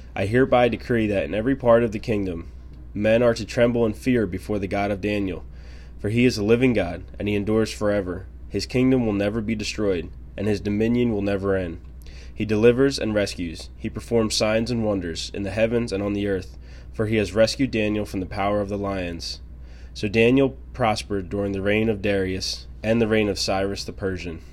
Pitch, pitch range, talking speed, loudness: 105 Hz, 95-110 Hz, 210 wpm, -23 LUFS